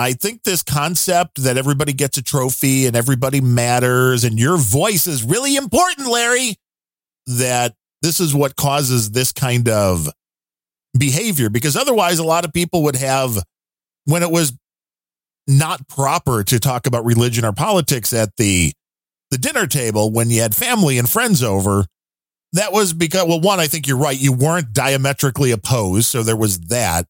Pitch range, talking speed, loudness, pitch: 115-160 Hz, 170 wpm, -16 LUFS, 130 Hz